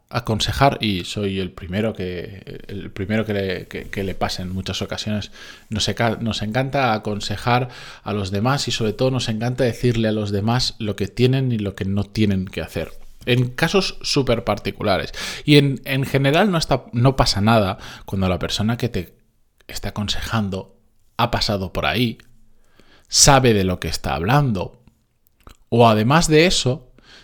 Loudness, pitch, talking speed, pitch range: -20 LUFS, 110 Hz, 165 wpm, 100-125 Hz